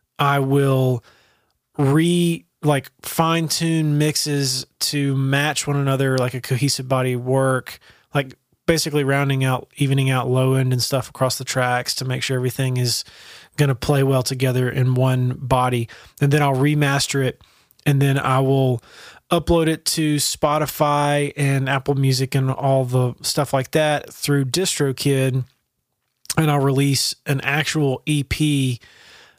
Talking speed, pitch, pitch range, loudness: 145 wpm, 135 Hz, 130-145 Hz, -20 LUFS